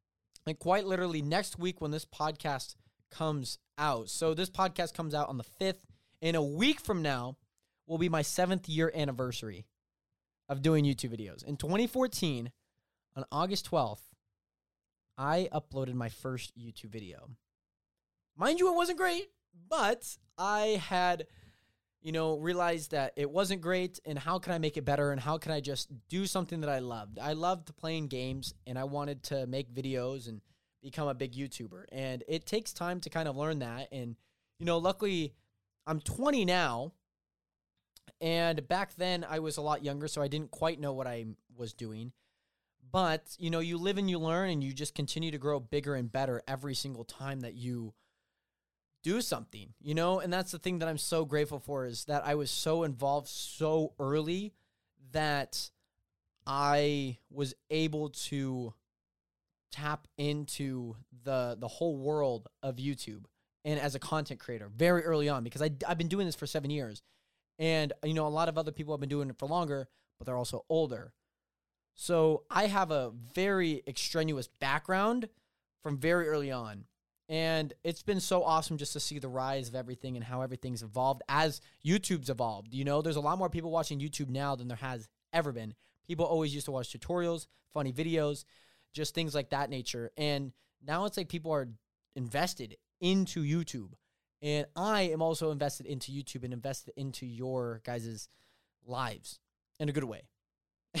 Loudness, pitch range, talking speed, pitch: -34 LUFS, 125-165 Hz, 180 wpm, 145 Hz